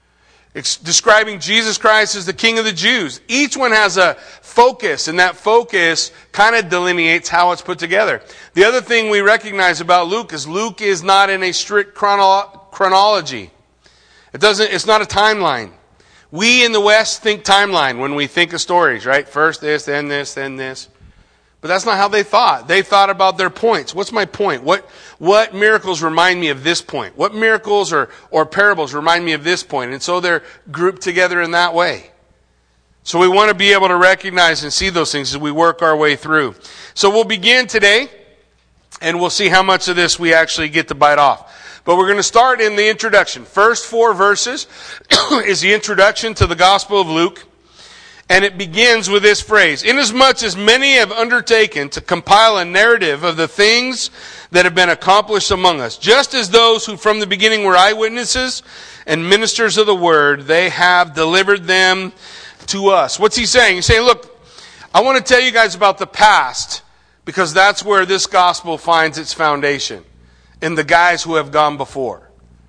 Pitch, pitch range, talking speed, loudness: 190 Hz, 165-215 Hz, 190 wpm, -13 LUFS